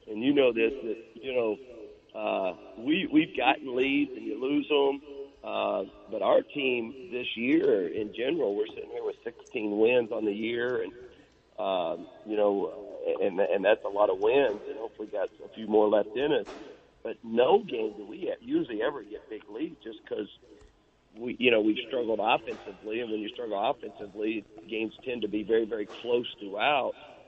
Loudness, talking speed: -29 LUFS, 190 wpm